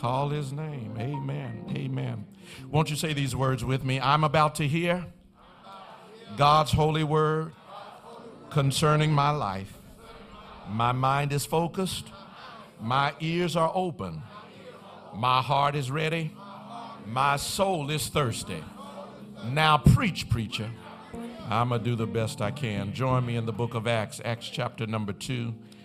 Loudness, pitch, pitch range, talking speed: -27 LUFS, 140 Hz, 115-155 Hz, 140 wpm